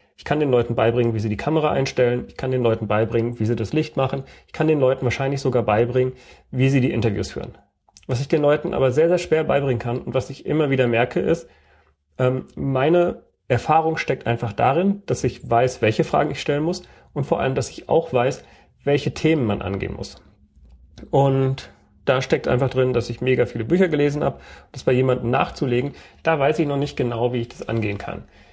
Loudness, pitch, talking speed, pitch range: -21 LUFS, 130 Hz, 210 wpm, 115-145 Hz